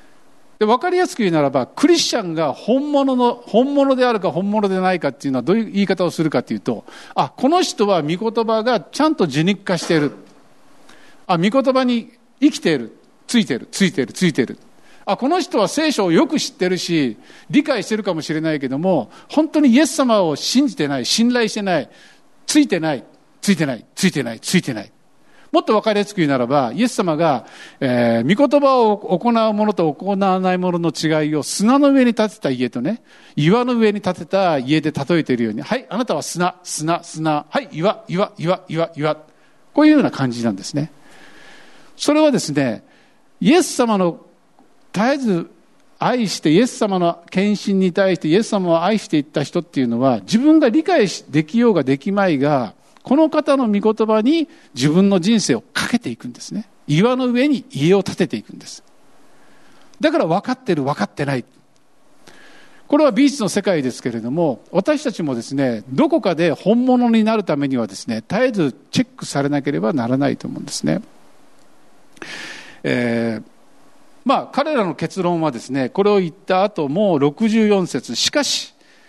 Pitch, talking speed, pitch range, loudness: 200 Hz, 360 characters per minute, 155-255 Hz, -18 LUFS